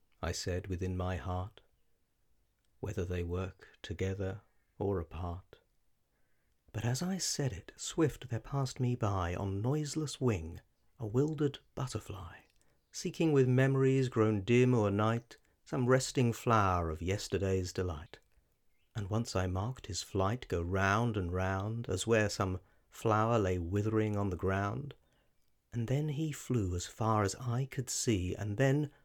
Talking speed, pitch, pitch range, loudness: 145 wpm, 105 Hz, 95-125 Hz, -34 LUFS